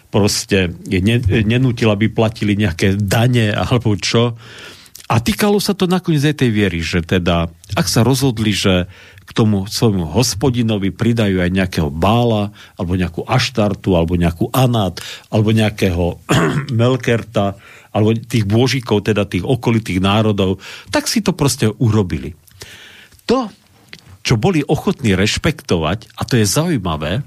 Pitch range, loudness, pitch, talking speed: 95-120 Hz, -16 LUFS, 110 Hz, 135 wpm